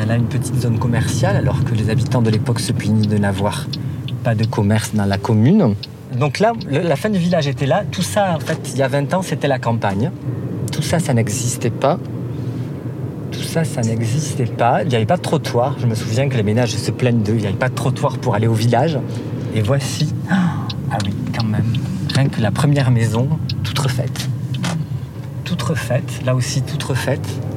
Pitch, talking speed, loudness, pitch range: 130 Hz, 210 wpm, -18 LUFS, 120-140 Hz